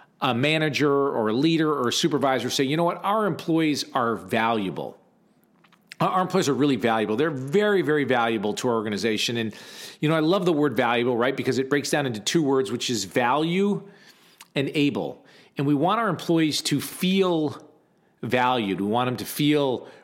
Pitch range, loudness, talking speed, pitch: 125-165 Hz, -23 LUFS, 185 wpm, 145 Hz